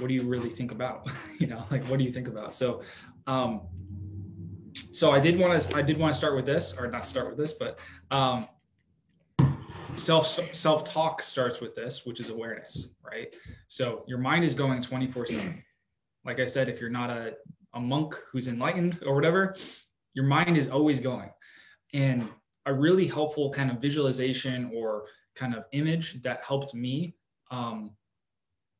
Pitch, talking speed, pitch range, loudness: 130 Hz, 175 wpm, 120-150 Hz, -29 LUFS